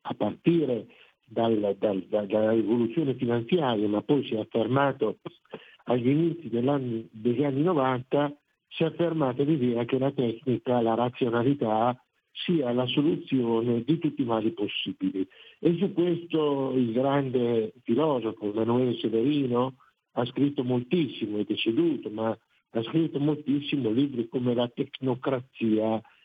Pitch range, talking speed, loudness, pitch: 115-145 Hz, 125 wpm, -27 LUFS, 125 Hz